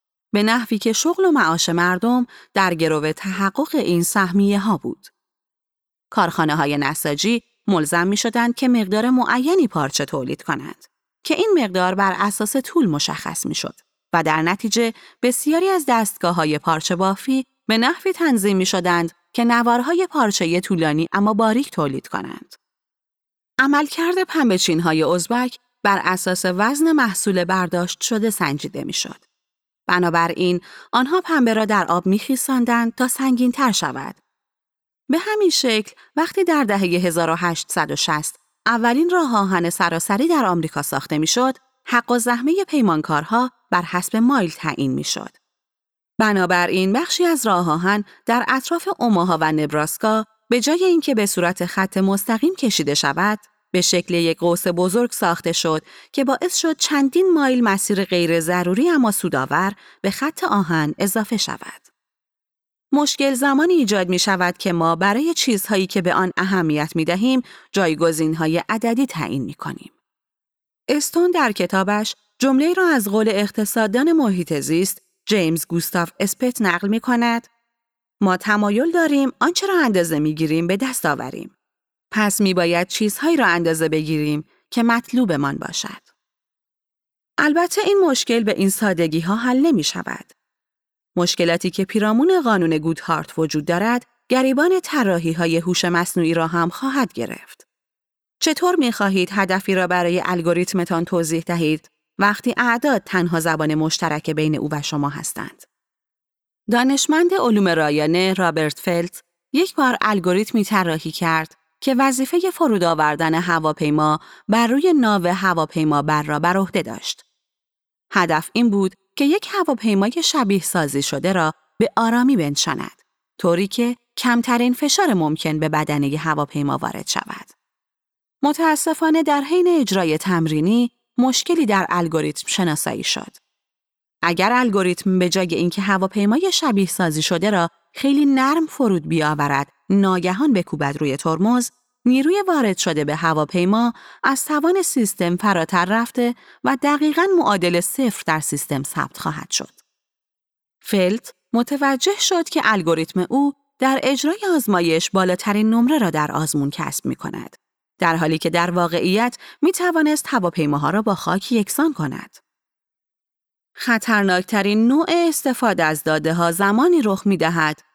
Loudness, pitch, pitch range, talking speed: -19 LUFS, 200 Hz, 170-255 Hz, 135 wpm